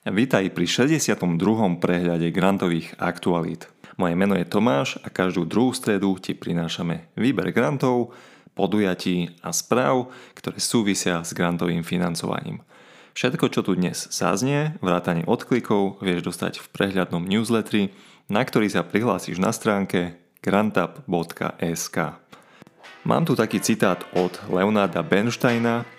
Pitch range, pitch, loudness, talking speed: 90-115 Hz, 95 Hz, -23 LUFS, 120 wpm